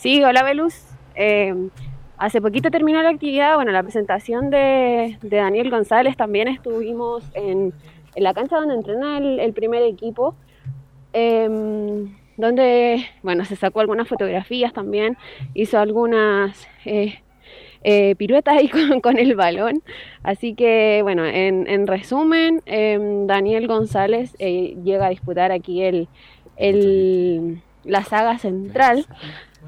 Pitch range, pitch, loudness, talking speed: 190-245 Hz, 215 Hz, -19 LUFS, 130 wpm